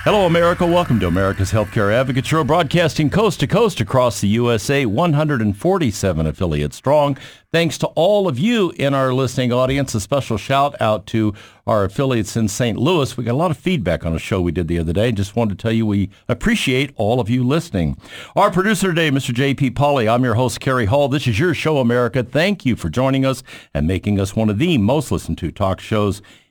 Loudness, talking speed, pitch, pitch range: -18 LUFS, 215 wpm, 125 Hz, 105-145 Hz